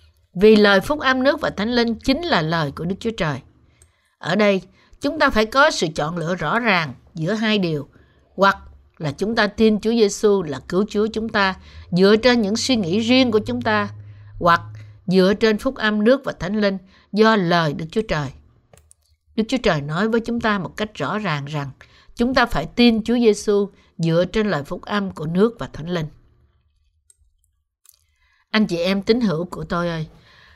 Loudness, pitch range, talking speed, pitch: -19 LUFS, 145-220 Hz, 195 wpm, 195 Hz